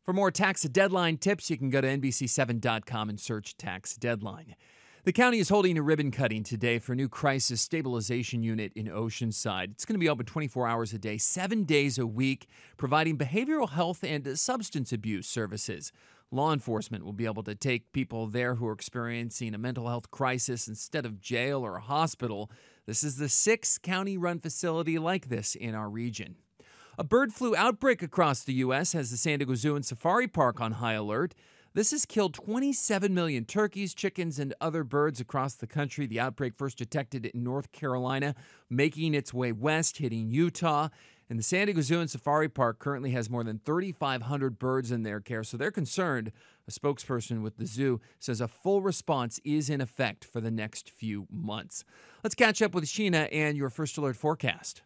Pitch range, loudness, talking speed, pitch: 115-160 Hz, -30 LUFS, 190 wpm, 135 Hz